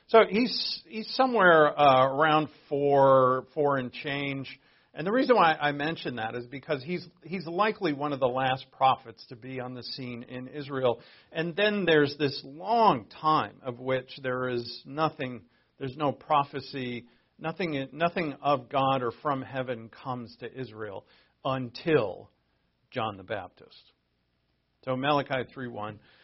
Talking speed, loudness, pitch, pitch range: 145 wpm, -27 LUFS, 135 Hz, 125-155 Hz